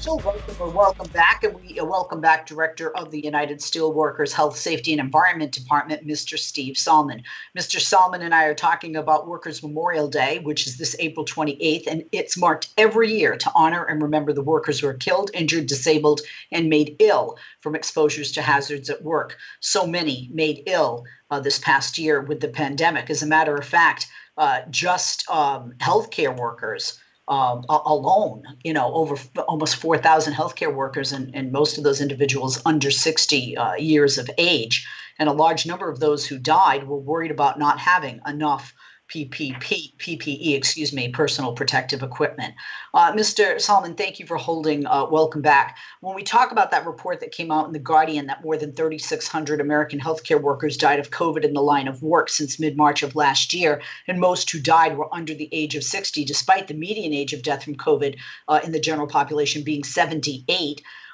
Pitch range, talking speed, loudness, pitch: 145-160 Hz, 190 wpm, -21 LUFS, 155 Hz